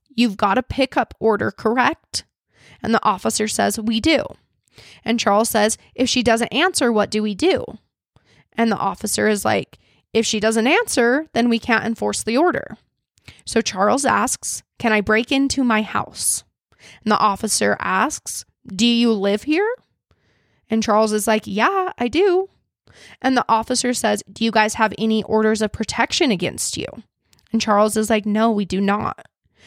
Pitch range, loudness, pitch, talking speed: 215-245 Hz, -19 LUFS, 225 Hz, 170 wpm